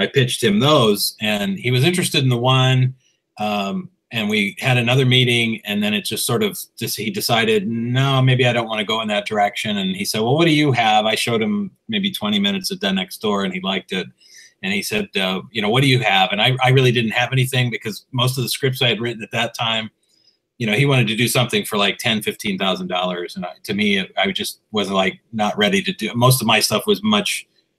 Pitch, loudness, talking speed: 130 Hz, -18 LUFS, 255 wpm